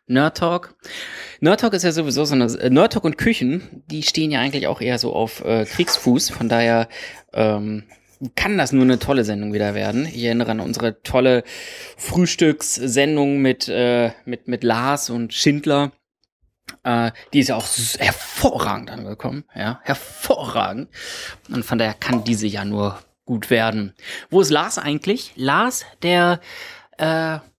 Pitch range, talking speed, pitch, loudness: 115-150 Hz, 160 wpm, 125 Hz, -20 LUFS